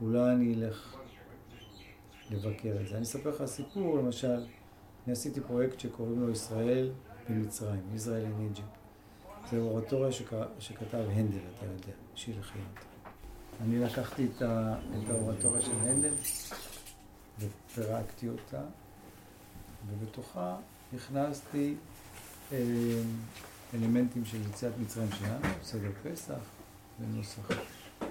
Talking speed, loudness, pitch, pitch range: 105 wpm, -35 LUFS, 110 Hz, 105-120 Hz